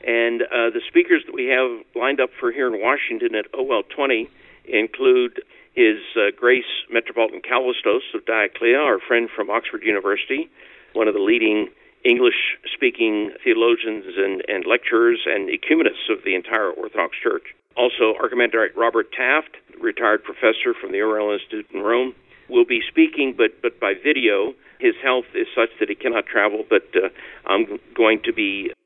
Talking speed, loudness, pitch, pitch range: 165 wpm, -20 LUFS, 370 Hz, 350-400 Hz